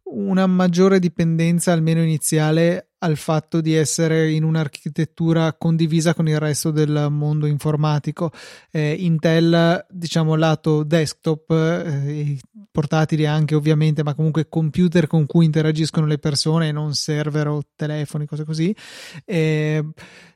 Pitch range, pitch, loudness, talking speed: 150-165 Hz, 160 Hz, -19 LUFS, 125 wpm